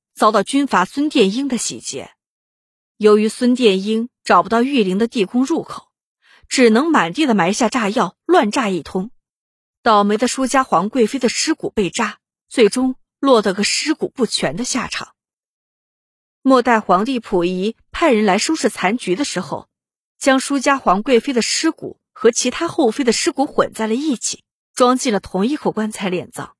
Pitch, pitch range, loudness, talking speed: 235 Hz, 210-270 Hz, -17 LUFS, 250 characters per minute